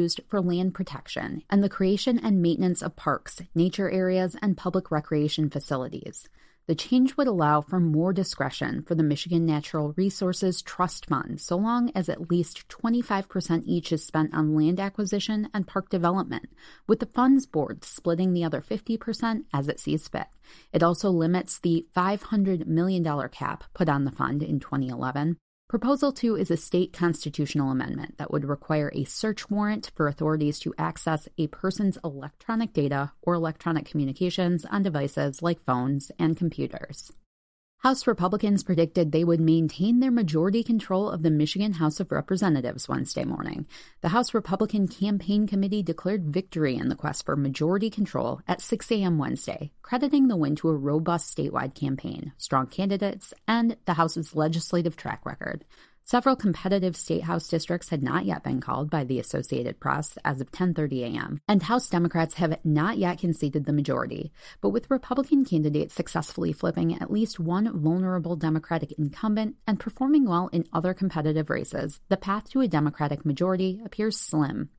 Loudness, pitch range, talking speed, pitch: -26 LUFS, 155-200 Hz, 165 wpm, 175 Hz